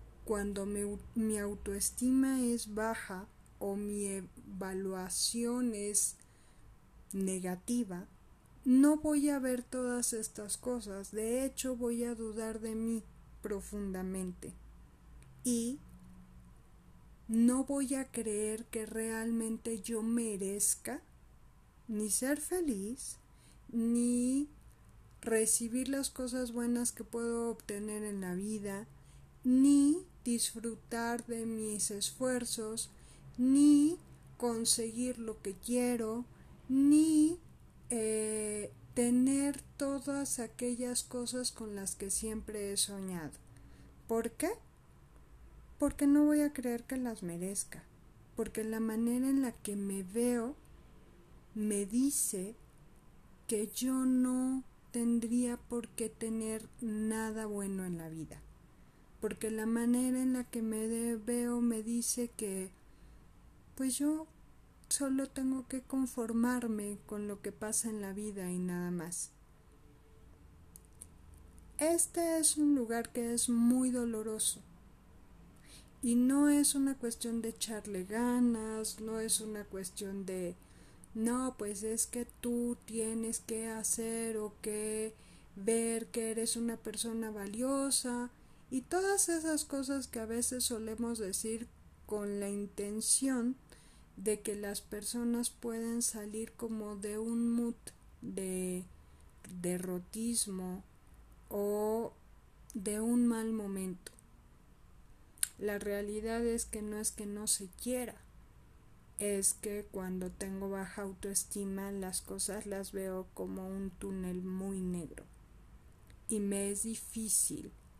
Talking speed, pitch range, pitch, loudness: 115 wpm, 200-245 Hz, 225 Hz, -35 LUFS